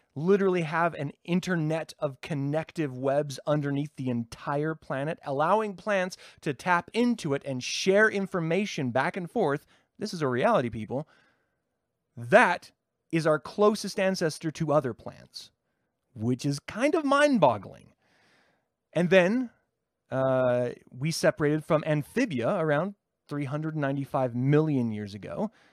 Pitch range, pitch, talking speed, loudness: 135-190 Hz, 155 Hz, 125 wpm, -27 LUFS